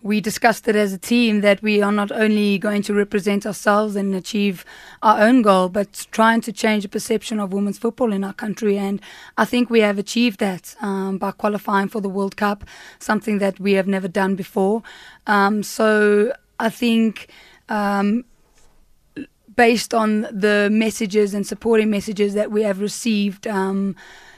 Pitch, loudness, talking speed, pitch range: 210 Hz, -19 LUFS, 170 wpm, 200-220 Hz